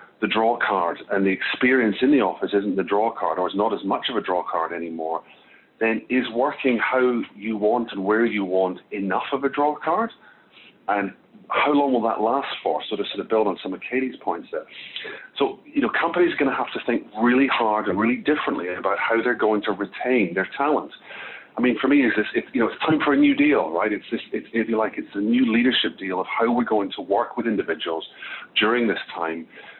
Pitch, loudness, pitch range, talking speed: 115 Hz, -22 LUFS, 100-140 Hz, 230 wpm